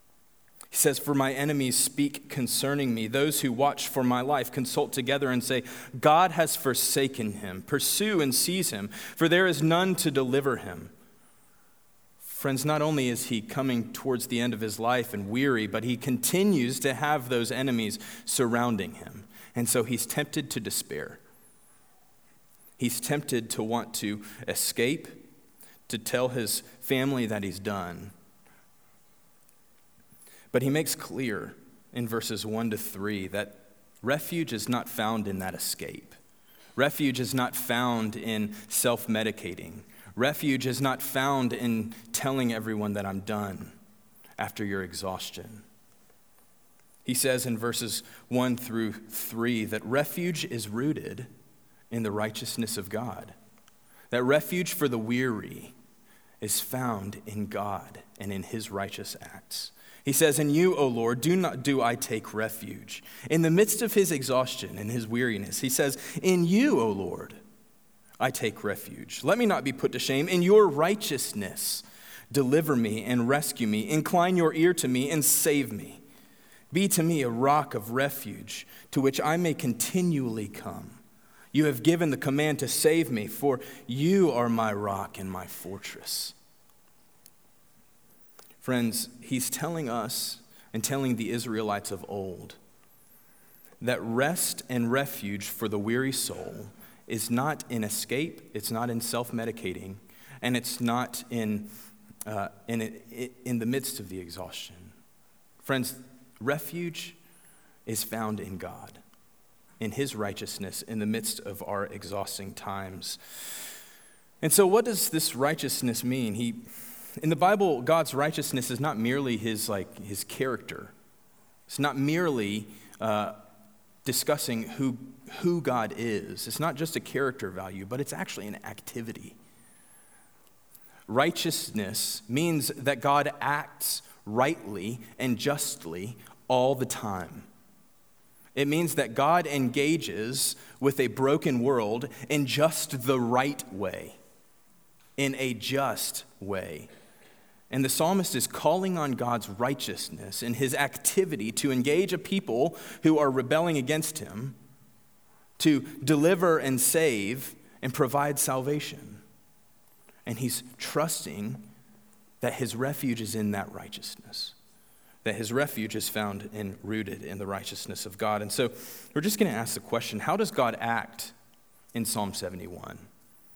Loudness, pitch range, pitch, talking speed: -28 LUFS, 110-145 Hz, 125 Hz, 145 wpm